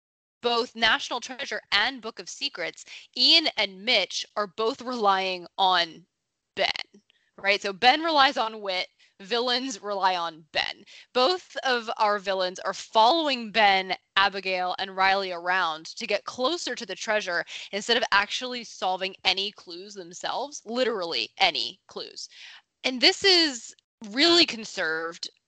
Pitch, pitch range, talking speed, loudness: 215 Hz, 190-250 Hz, 135 wpm, -24 LUFS